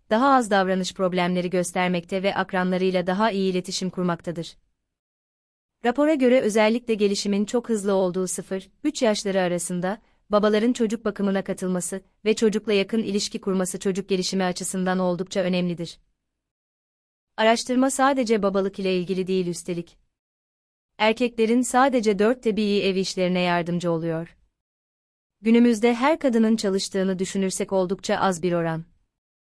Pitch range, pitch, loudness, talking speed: 180-220 Hz, 195 Hz, -23 LUFS, 120 wpm